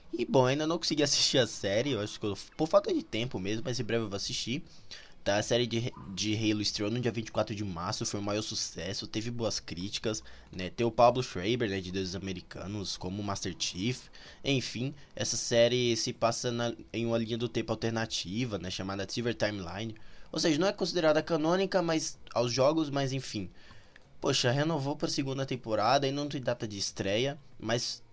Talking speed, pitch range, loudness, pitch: 200 wpm, 105-130 Hz, -31 LUFS, 115 Hz